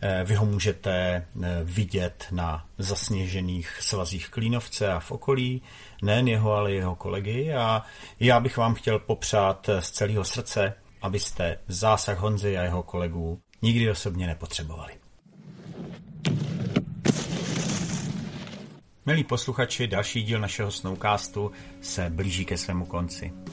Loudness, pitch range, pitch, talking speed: -27 LUFS, 95-125 Hz, 105 Hz, 115 wpm